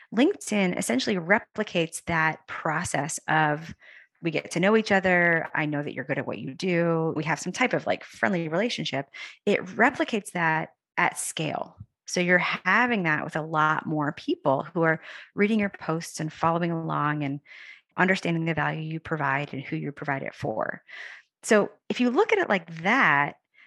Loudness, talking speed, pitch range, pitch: -26 LUFS, 180 wpm, 155-205 Hz, 165 Hz